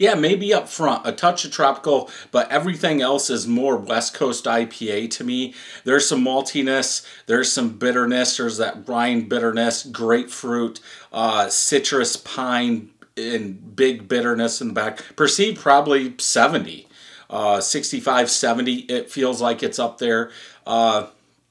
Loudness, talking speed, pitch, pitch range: -20 LUFS, 140 wpm, 125 Hz, 115-140 Hz